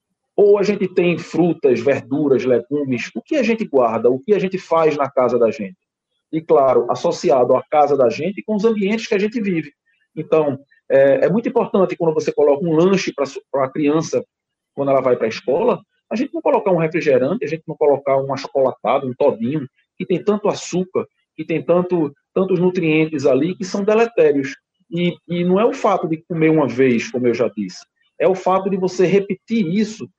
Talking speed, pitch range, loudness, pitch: 205 wpm, 140-195 Hz, -18 LUFS, 170 Hz